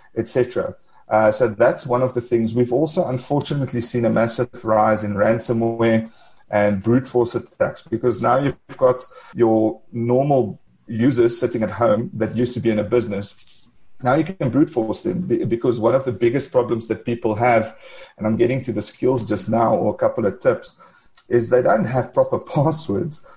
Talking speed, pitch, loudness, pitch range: 185 wpm, 120 Hz, -20 LUFS, 110-125 Hz